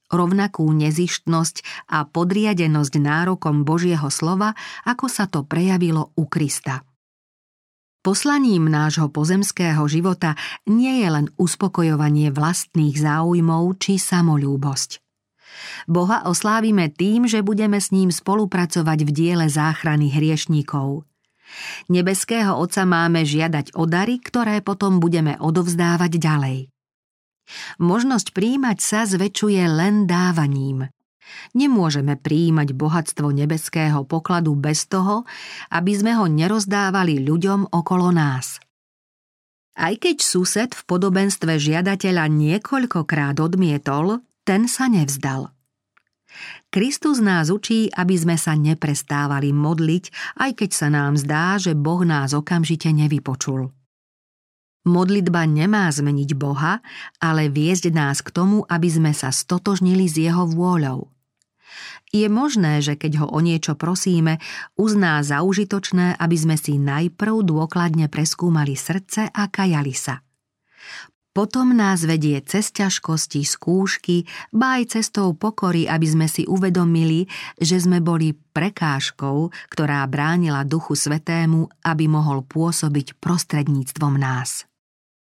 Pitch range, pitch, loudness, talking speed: 150-190 Hz, 165 Hz, -19 LUFS, 115 wpm